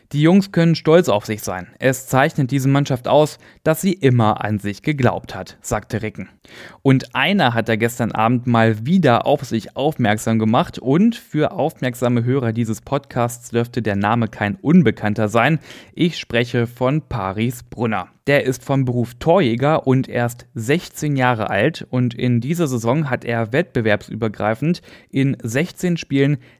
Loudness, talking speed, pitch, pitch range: -18 LUFS, 160 wpm, 125 Hz, 115-145 Hz